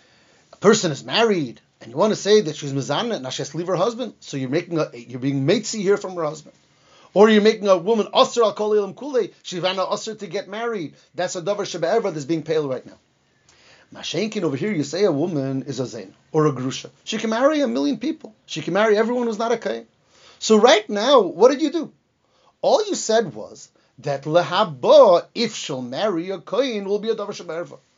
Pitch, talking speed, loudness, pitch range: 195 Hz, 220 wpm, -20 LUFS, 155-220 Hz